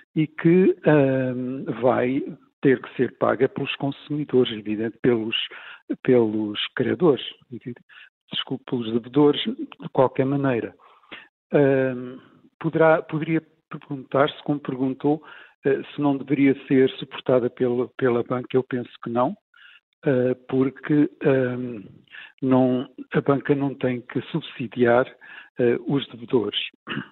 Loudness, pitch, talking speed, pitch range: -23 LUFS, 135 Hz, 120 wpm, 125-150 Hz